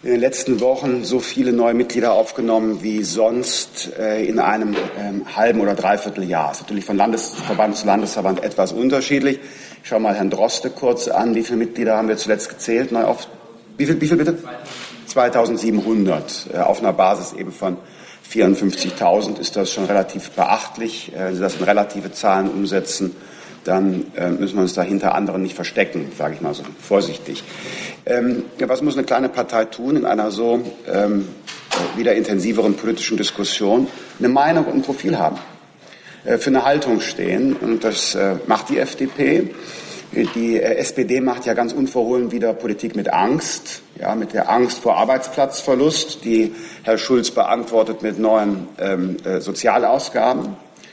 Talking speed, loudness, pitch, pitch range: 165 wpm, -19 LUFS, 110 Hz, 100-120 Hz